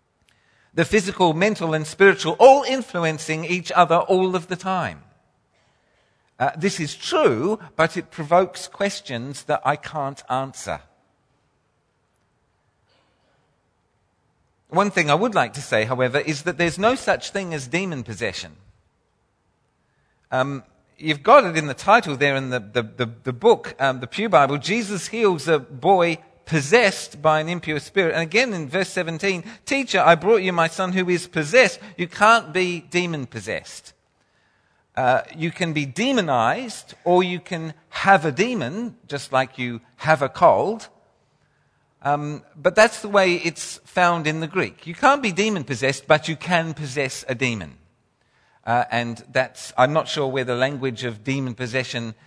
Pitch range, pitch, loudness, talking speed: 135-185 Hz, 160 Hz, -21 LUFS, 160 wpm